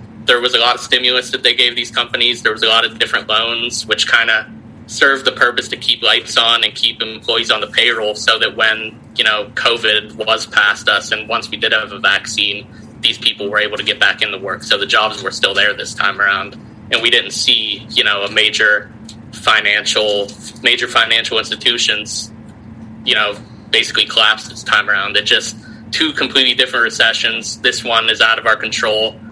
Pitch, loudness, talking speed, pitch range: 110 Hz, -13 LUFS, 205 wpm, 110-115 Hz